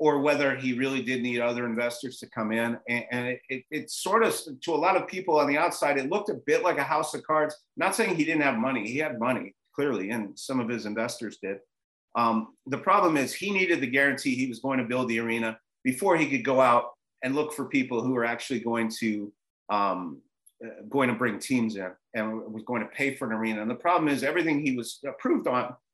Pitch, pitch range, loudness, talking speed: 125 Hz, 115-140 Hz, -27 LUFS, 240 wpm